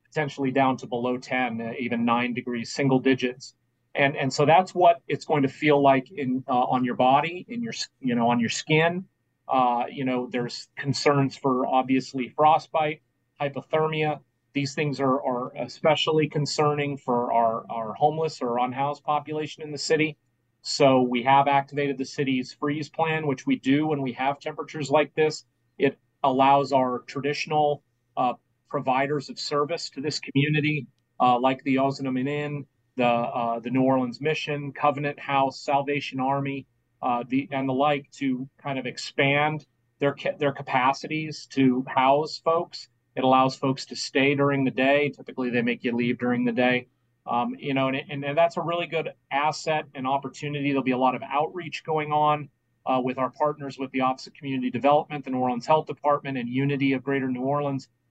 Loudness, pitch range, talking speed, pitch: -25 LUFS, 125-150 Hz, 180 wpm, 135 Hz